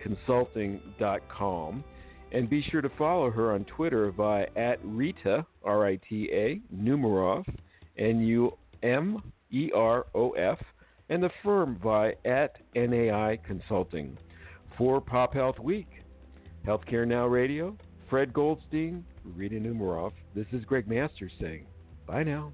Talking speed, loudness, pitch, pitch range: 130 wpm, -29 LUFS, 110 Hz, 95-130 Hz